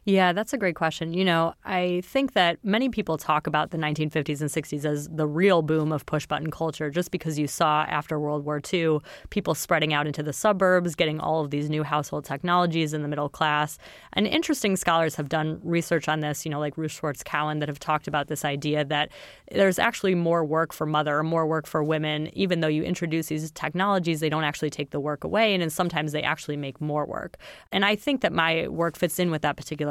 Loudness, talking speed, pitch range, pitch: -25 LUFS, 230 wpm, 150-175 Hz, 155 Hz